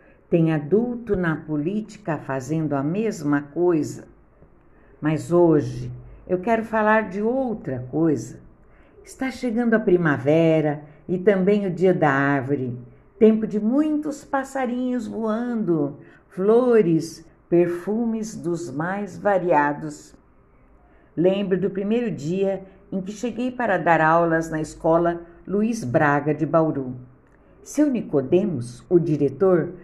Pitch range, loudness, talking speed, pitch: 155-215 Hz, -22 LUFS, 115 wpm, 175 Hz